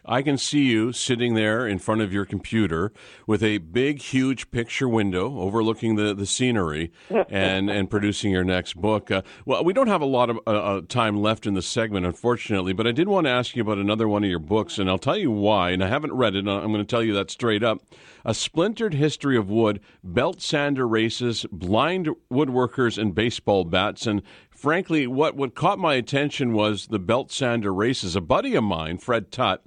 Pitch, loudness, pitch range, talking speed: 110 Hz, -23 LUFS, 100-125 Hz, 210 wpm